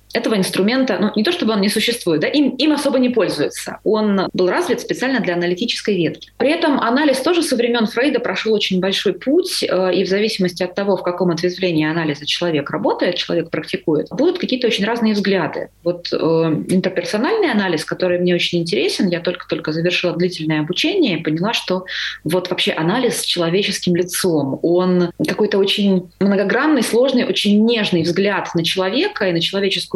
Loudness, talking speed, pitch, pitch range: -17 LUFS, 175 wpm, 190 Hz, 175-230 Hz